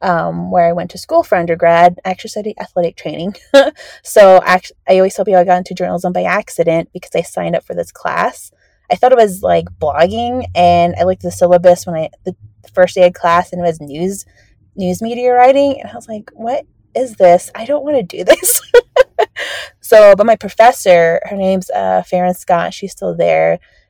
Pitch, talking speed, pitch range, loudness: 185 Hz, 210 wpm, 175-225 Hz, -12 LUFS